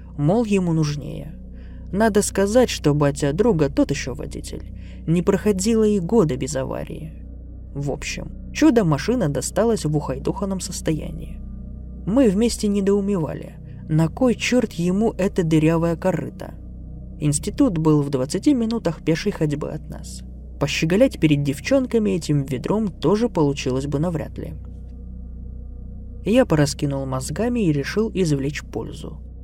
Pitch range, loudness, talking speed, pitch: 130-200 Hz, -21 LUFS, 120 wpm, 155 Hz